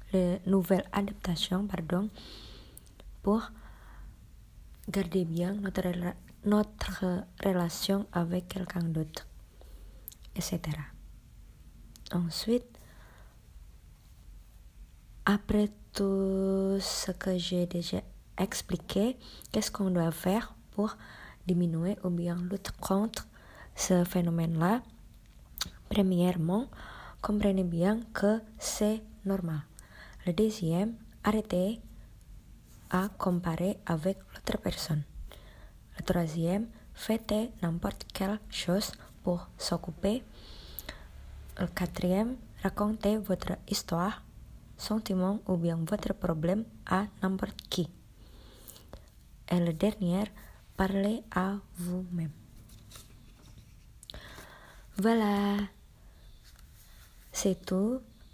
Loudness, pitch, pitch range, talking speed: -32 LUFS, 185 Hz, 175-200 Hz, 80 wpm